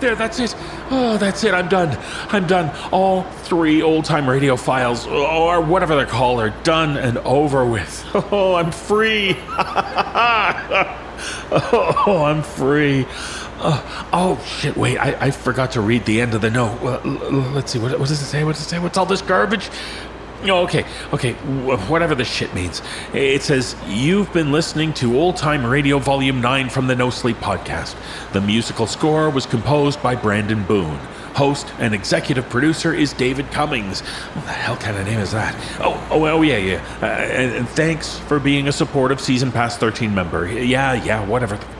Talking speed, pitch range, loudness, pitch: 180 wpm, 120-160 Hz, -18 LUFS, 140 Hz